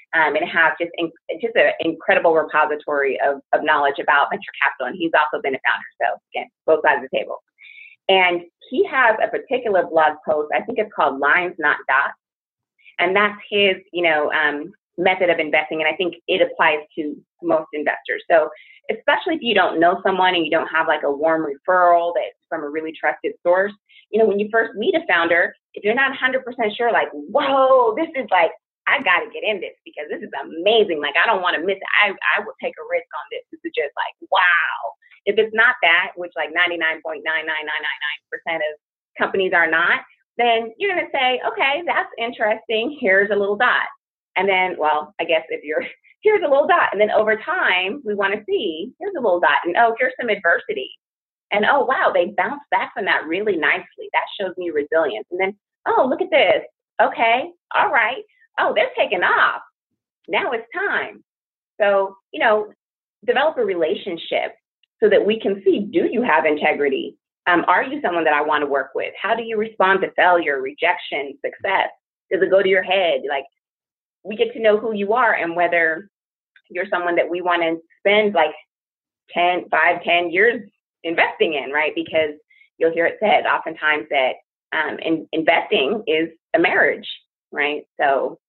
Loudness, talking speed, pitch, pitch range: -19 LUFS, 195 wpm, 195 Hz, 165-265 Hz